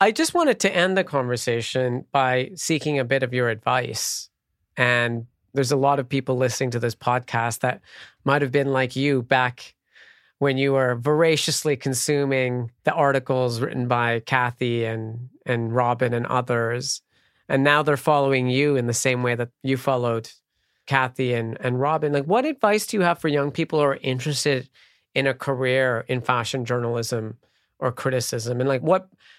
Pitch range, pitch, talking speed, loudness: 125-145 Hz, 130 Hz, 175 wpm, -22 LUFS